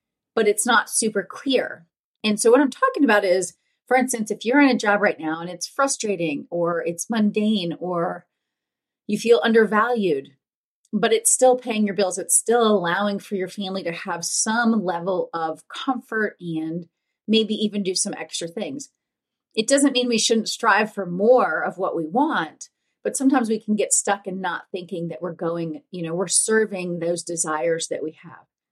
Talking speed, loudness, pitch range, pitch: 185 wpm, -21 LUFS, 175-235 Hz, 210 Hz